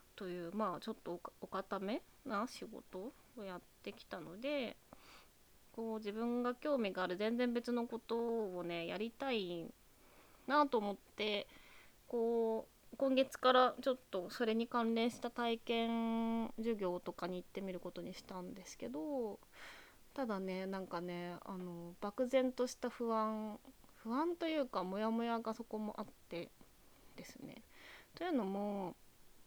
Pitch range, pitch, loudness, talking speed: 195-245 Hz, 225 Hz, -40 LUFS, 265 characters per minute